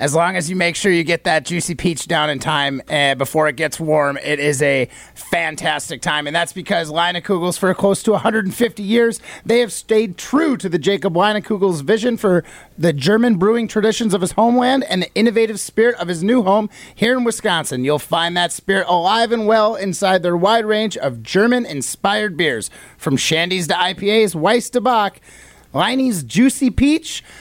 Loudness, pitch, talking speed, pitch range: -17 LUFS, 185 Hz, 190 wpm, 165-220 Hz